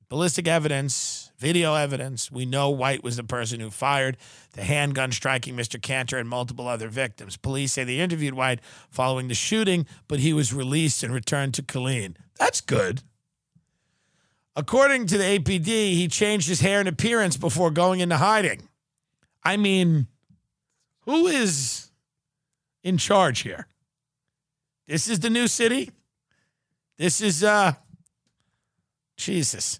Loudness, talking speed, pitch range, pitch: -23 LUFS, 140 wpm, 130-180 Hz, 145 Hz